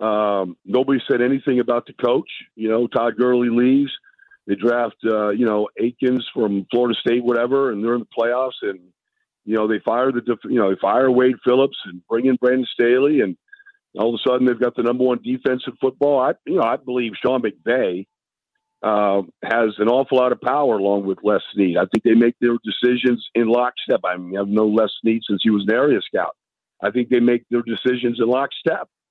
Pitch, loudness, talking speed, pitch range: 120 Hz, -19 LUFS, 210 wpm, 110-125 Hz